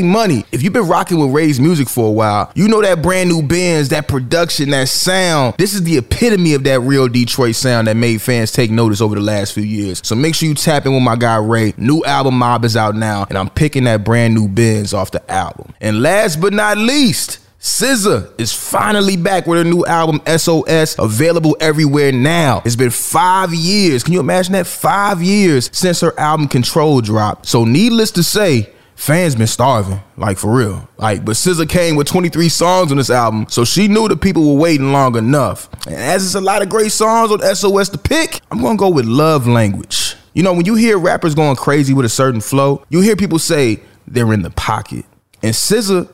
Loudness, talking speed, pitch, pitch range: -13 LUFS, 220 wpm, 145 Hz, 115-180 Hz